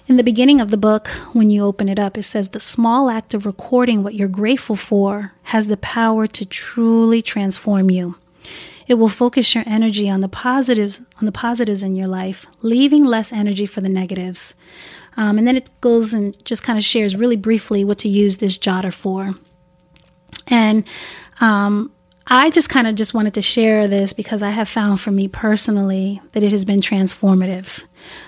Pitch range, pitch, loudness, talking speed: 200-230 Hz, 210 Hz, -16 LUFS, 190 wpm